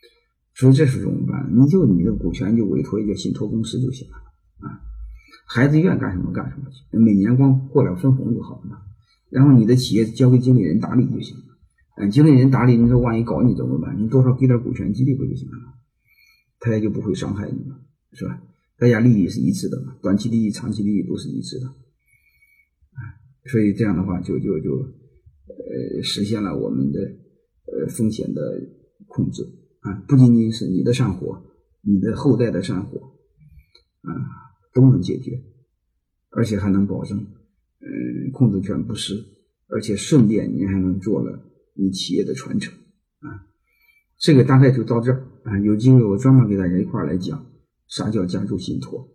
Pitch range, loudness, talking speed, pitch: 100-130 Hz, -19 LUFS, 275 characters per minute, 115 Hz